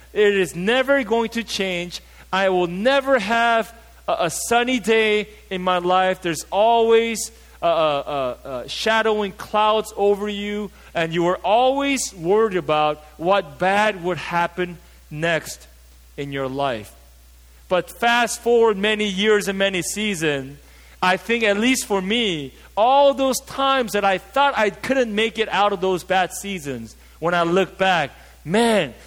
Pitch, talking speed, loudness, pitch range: 200 Hz, 155 wpm, -20 LUFS, 175-225 Hz